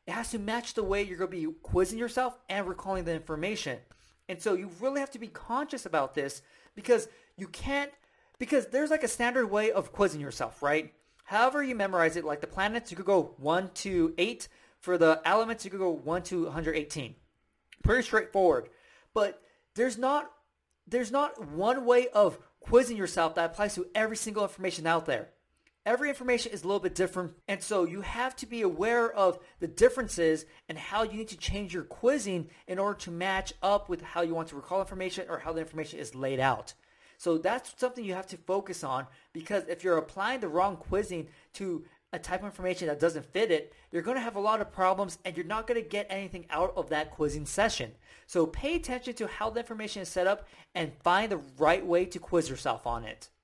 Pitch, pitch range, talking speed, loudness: 190 Hz, 170-230 Hz, 210 wpm, -31 LUFS